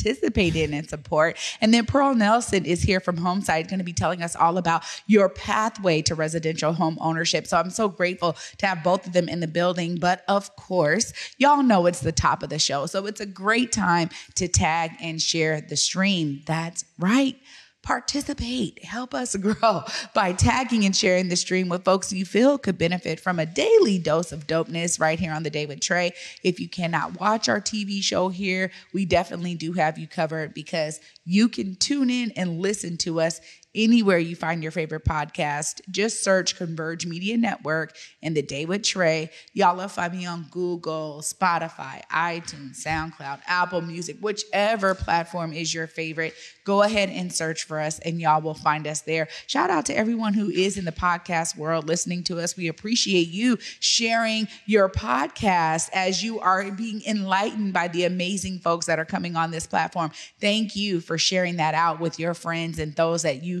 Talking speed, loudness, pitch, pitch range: 190 wpm, -24 LUFS, 175 Hz, 160-195 Hz